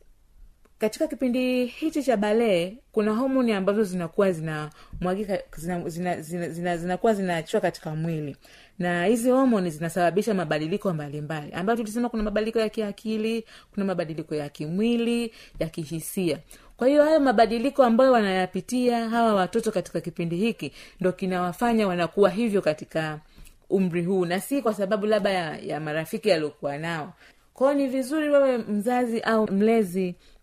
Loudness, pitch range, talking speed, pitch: -25 LUFS, 175-230 Hz, 150 wpm, 200 Hz